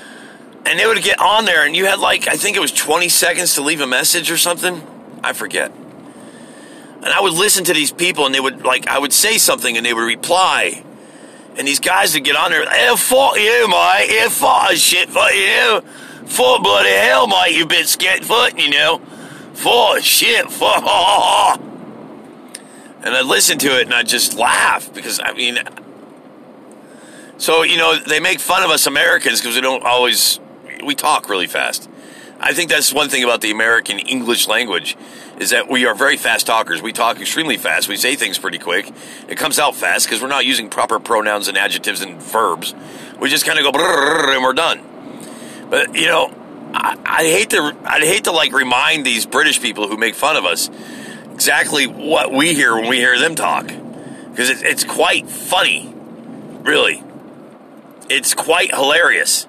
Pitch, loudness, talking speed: 175 Hz, -13 LUFS, 190 wpm